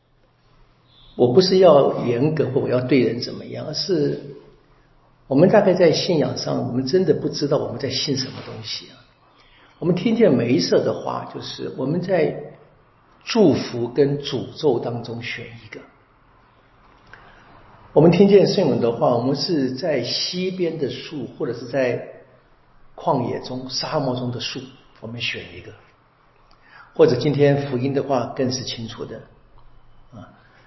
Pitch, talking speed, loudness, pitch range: 130 Hz, 215 characters per minute, -20 LUFS, 120-145 Hz